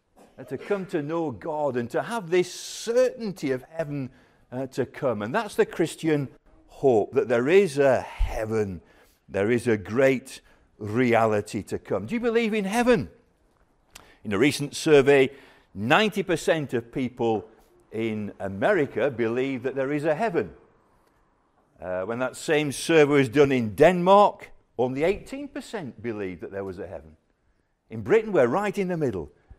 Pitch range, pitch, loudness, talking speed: 115-180 Hz, 140 Hz, -24 LUFS, 155 wpm